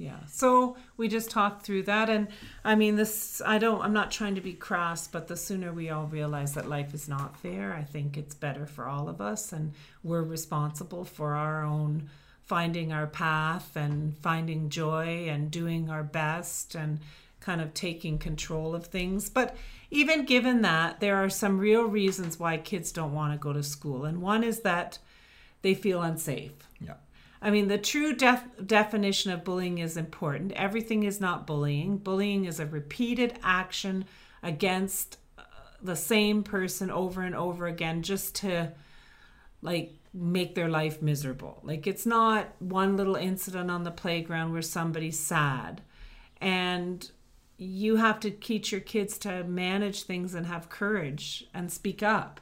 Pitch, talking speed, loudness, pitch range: 175 Hz, 170 wpm, -30 LUFS, 155-200 Hz